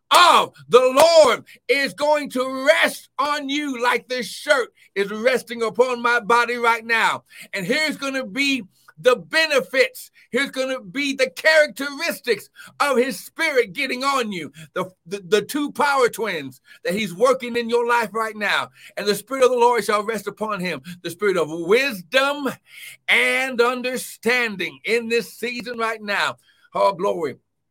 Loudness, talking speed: -20 LUFS, 165 wpm